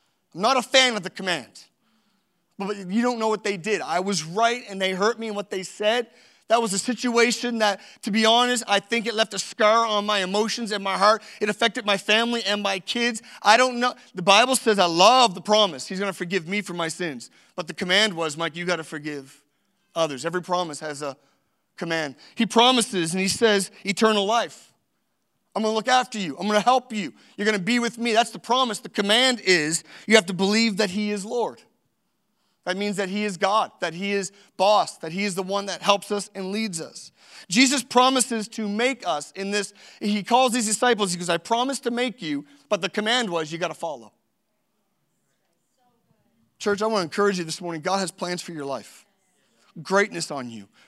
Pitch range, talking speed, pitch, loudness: 185-230 Hz, 215 wpm, 205 Hz, -22 LUFS